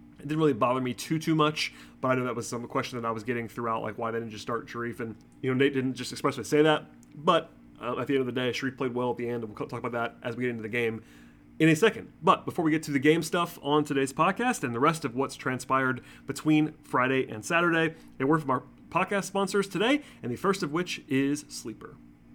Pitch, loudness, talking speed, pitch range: 130 Hz, -28 LUFS, 265 wpm, 120-155 Hz